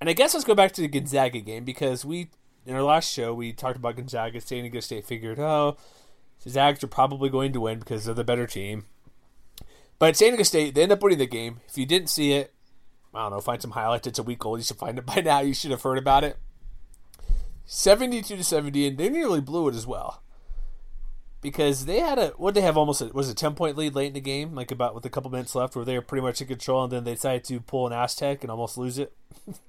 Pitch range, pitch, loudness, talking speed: 120-145 Hz, 130 Hz, -25 LUFS, 260 wpm